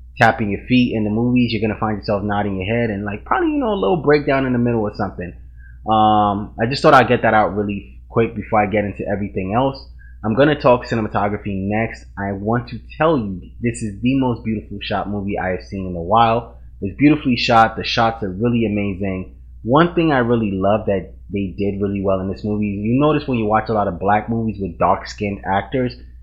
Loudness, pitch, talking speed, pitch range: -18 LUFS, 105 Hz, 230 wpm, 100-120 Hz